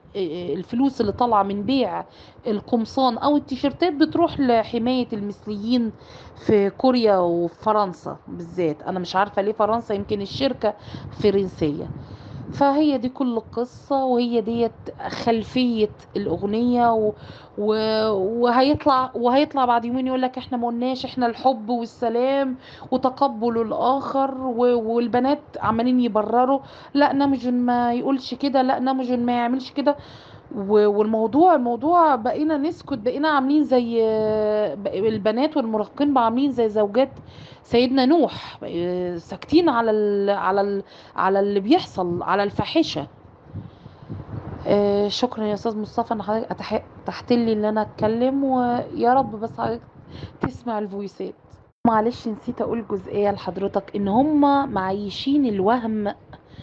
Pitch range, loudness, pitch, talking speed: 210-260 Hz, -22 LUFS, 235 Hz, 115 wpm